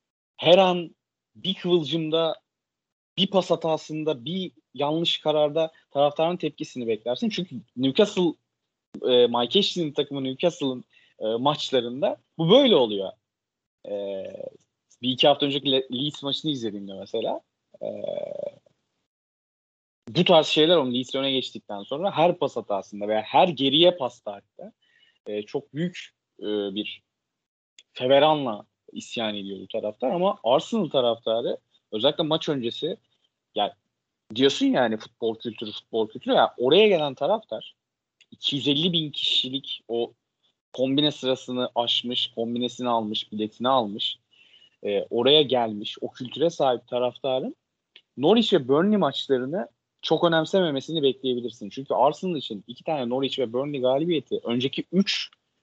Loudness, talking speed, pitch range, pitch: -24 LUFS, 125 wpm, 120-165 Hz, 140 Hz